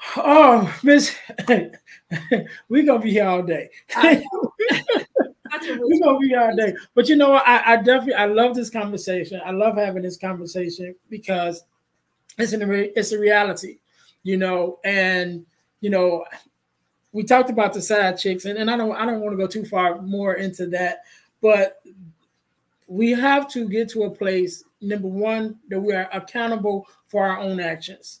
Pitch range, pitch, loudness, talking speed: 185-235 Hz, 205 Hz, -20 LUFS, 170 wpm